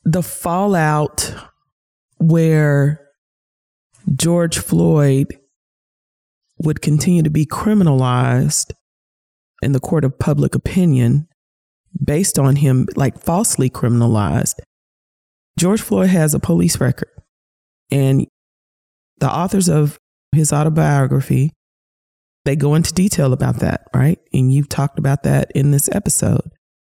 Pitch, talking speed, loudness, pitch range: 145 Hz, 110 wpm, -16 LUFS, 135-165 Hz